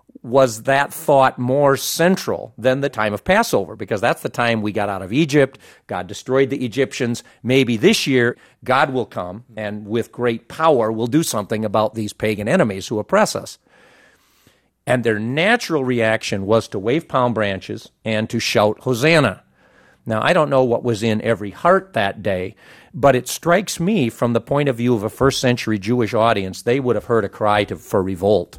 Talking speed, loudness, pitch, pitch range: 190 wpm, -18 LUFS, 120 Hz, 110-135 Hz